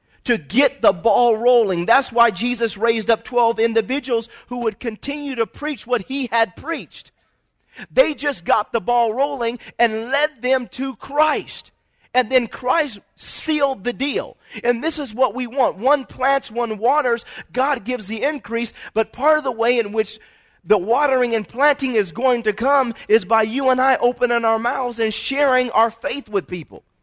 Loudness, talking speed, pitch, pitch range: -19 LUFS, 180 wpm, 245 Hz, 230-270 Hz